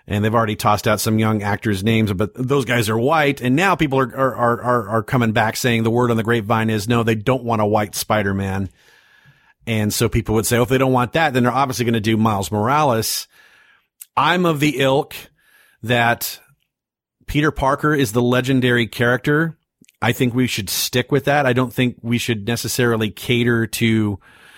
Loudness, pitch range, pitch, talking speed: -18 LUFS, 110-130 Hz, 120 Hz, 200 wpm